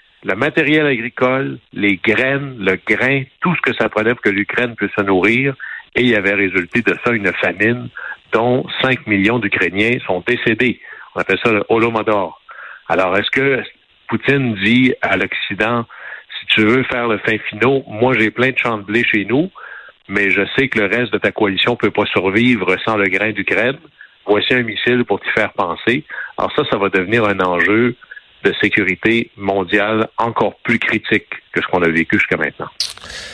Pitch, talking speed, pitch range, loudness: 115 Hz, 185 wpm, 100-125 Hz, -16 LUFS